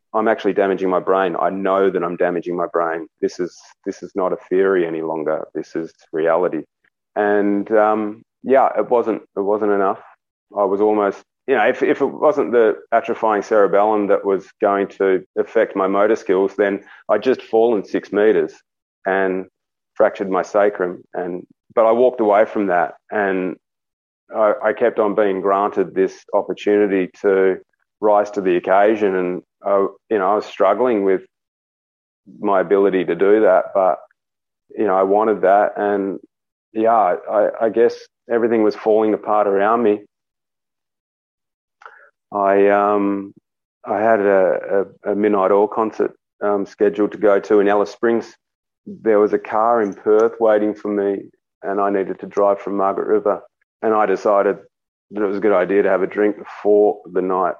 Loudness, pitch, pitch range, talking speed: -18 LUFS, 100 Hz, 95-105 Hz, 170 wpm